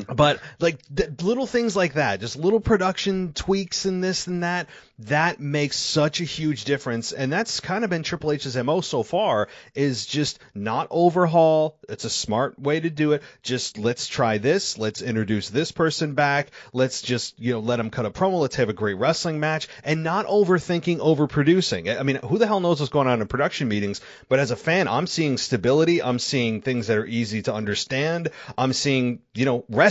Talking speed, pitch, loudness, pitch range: 205 wpm, 145 Hz, -23 LUFS, 125-170 Hz